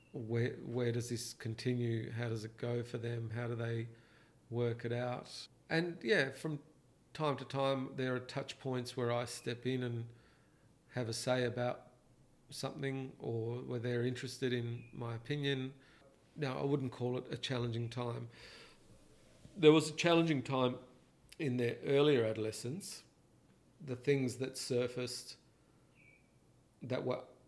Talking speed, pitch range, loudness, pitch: 145 wpm, 120-135 Hz, -37 LUFS, 125 Hz